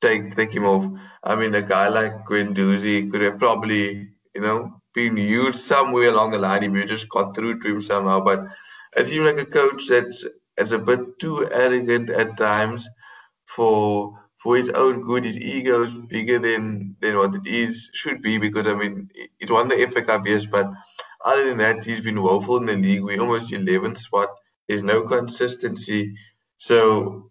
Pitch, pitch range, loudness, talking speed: 110 Hz, 100-120 Hz, -21 LUFS, 190 wpm